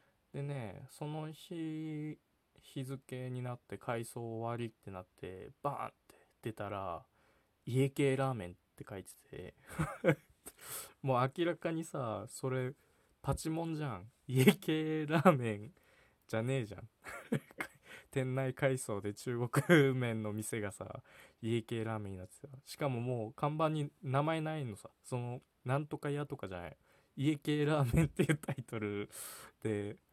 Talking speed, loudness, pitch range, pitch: 270 characters per minute, -37 LUFS, 110-150 Hz, 130 Hz